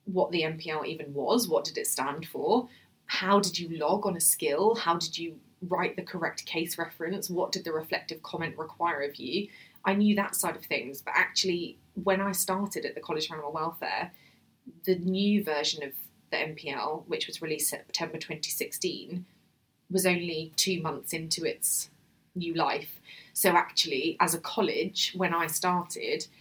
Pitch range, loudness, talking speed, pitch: 160-190 Hz, -29 LUFS, 175 wpm, 170 Hz